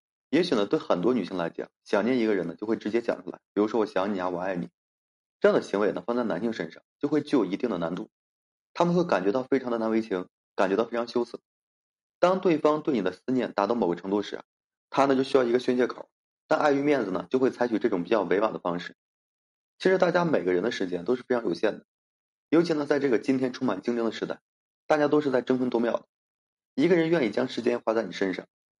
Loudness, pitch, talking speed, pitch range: -27 LUFS, 125 Hz, 360 characters per minute, 110-145 Hz